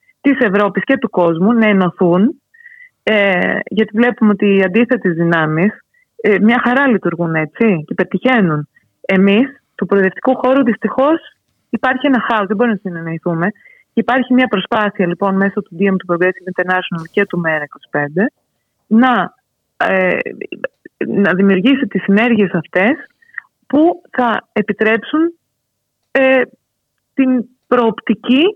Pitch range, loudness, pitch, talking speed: 190-255 Hz, -14 LUFS, 215 Hz, 125 wpm